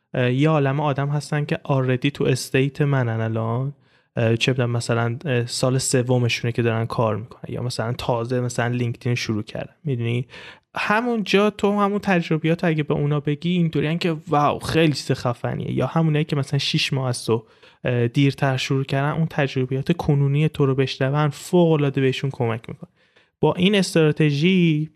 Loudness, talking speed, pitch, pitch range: -21 LUFS, 155 wpm, 140 Hz, 125-155 Hz